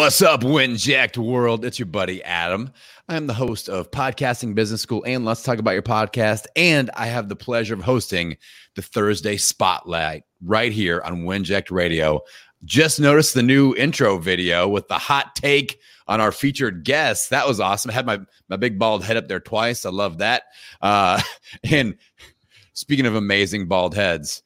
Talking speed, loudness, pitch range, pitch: 180 wpm, -20 LUFS, 100-130 Hz, 110 Hz